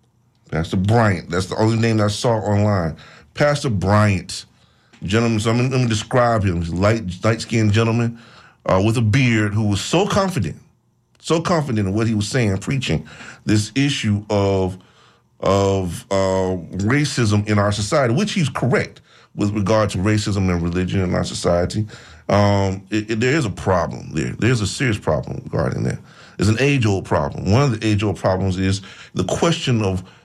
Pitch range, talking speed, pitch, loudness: 95-115 Hz, 175 wpm, 105 Hz, -19 LUFS